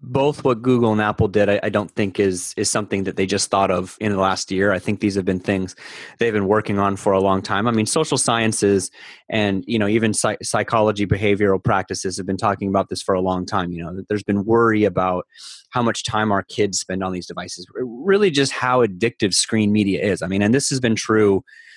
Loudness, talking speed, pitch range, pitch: -19 LUFS, 235 wpm, 95-110 Hz, 100 Hz